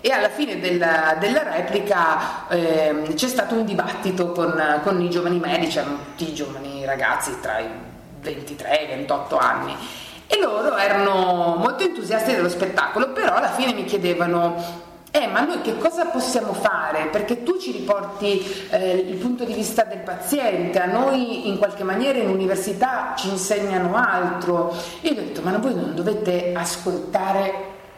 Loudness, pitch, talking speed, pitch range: -22 LUFS, 195 Hz, 165 wpm, 170-225 Hz